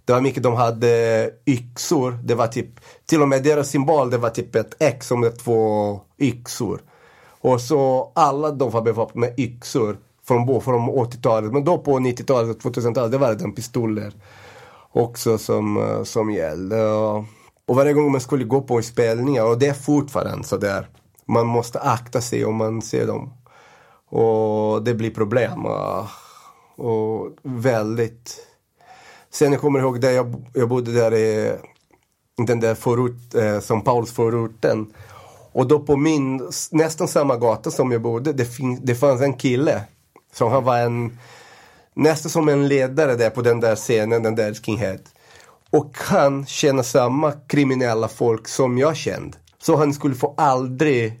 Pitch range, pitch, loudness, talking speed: 115-140 Hz, 120 Hz, -20 LUFS, 160 wpm